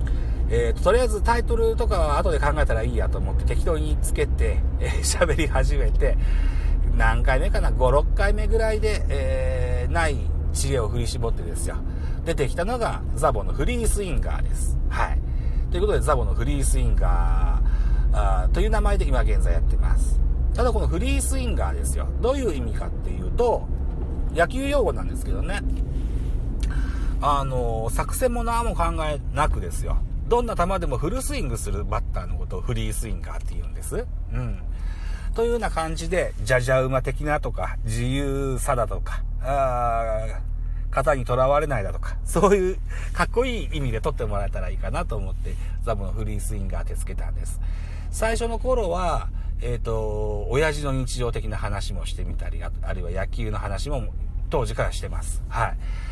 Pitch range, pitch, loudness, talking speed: 65-110 Hz, 80 Hz, -25 LUFS, 360 characters per minute